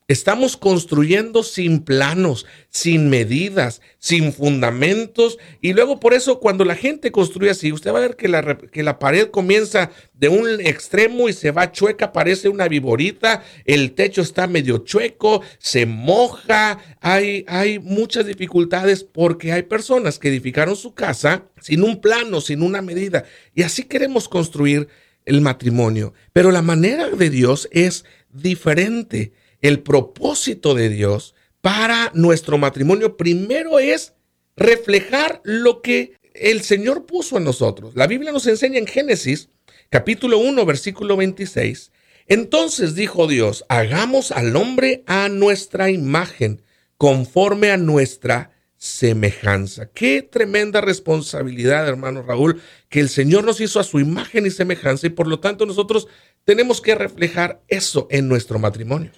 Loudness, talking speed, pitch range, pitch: -17 LUFS, 145 wpm, 145-215 Hz, 180 Hz